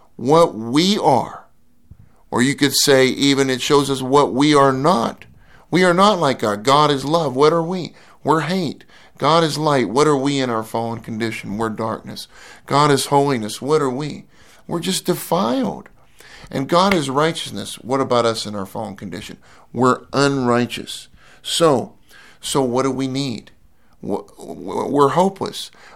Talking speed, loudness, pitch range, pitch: 160 wpm, -18 LUFS, 125-160 Hz, 140 Hz